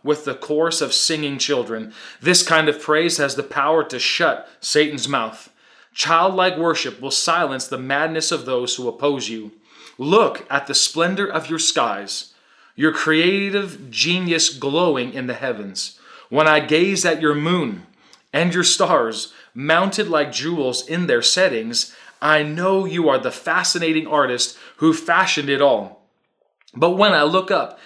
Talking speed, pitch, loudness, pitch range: 155 wpm, 155 Hz, -18 LUFS, 140-170 Hz